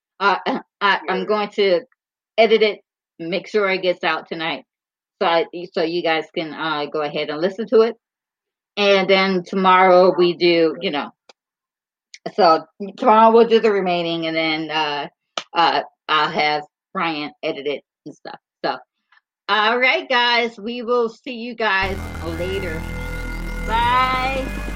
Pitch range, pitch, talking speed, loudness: 165-225 Hz, 190 Hz, 150 wpm, -19 LUFS